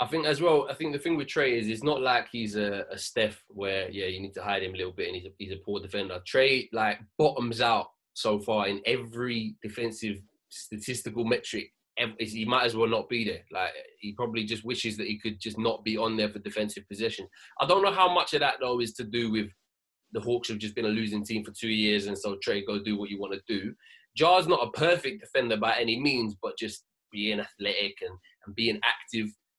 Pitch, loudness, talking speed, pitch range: 110 Hz, -29 LUFS, 240 wpm, 105-120 Hz